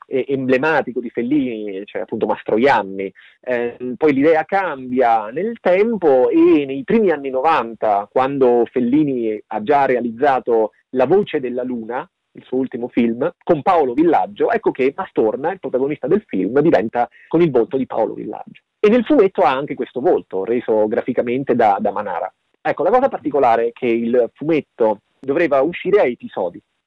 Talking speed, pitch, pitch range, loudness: 160 wpm, 130 Hz, 120-165 Hz, -18 LUFS